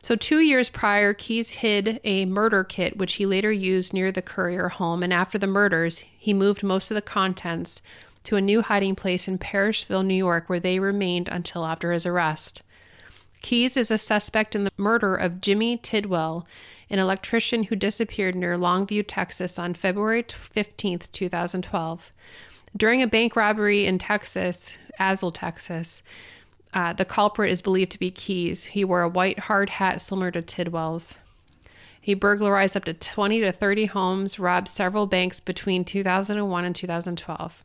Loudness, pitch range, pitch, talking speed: -23 LUFS, 175-205 Hz, 190 Hz, 165 wpm